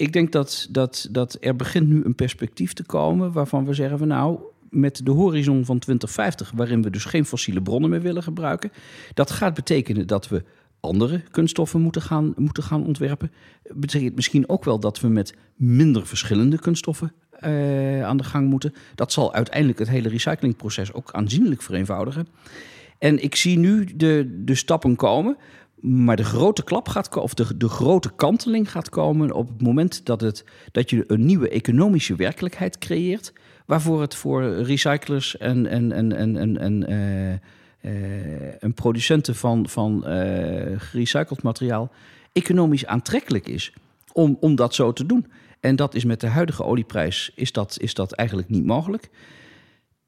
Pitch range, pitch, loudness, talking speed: 115-155 Hz, 130 Hz, -22 LUFS, 170 wpm